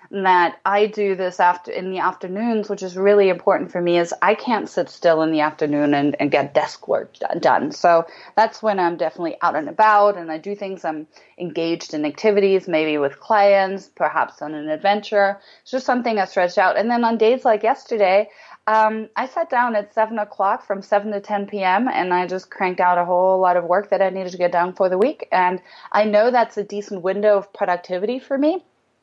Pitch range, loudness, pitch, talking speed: 175-210 Hz, -19 LUFS, 195 Hz, 215 wpm